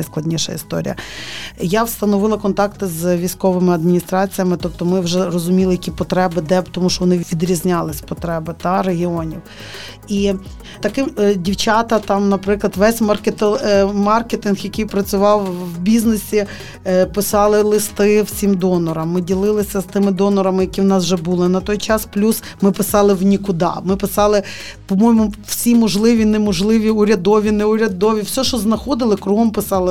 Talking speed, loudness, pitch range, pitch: 135 wpm, -16 LUFS, 185-210 Hz, 200 Hz